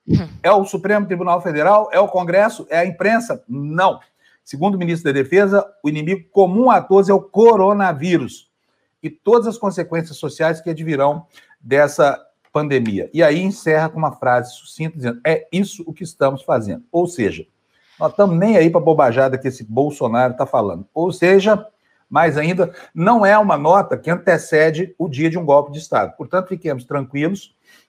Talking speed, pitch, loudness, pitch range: 175 wpm, 170 Hz, -16 LUFS, 150-195 Hz